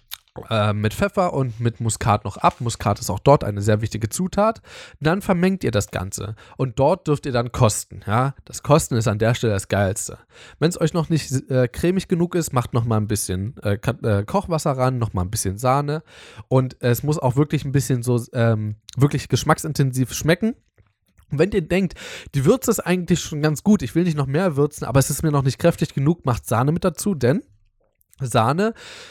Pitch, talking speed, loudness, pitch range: 130 Hz, 210 wpm, -21 LUFS, 110-160 Hz